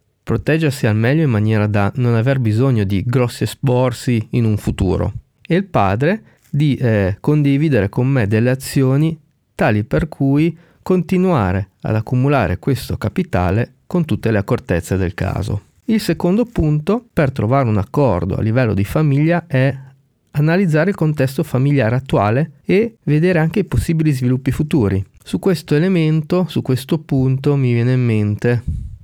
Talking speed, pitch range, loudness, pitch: 150 wpm, 110-155 Hz, -17 LUFS, 130 Hz